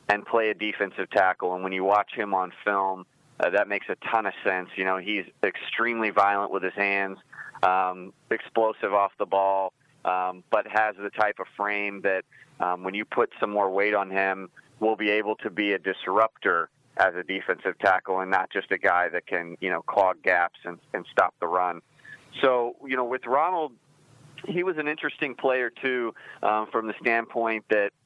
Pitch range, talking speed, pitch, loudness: 95-115 Hz, 195 wpm, 100 Hz, -26 LUFS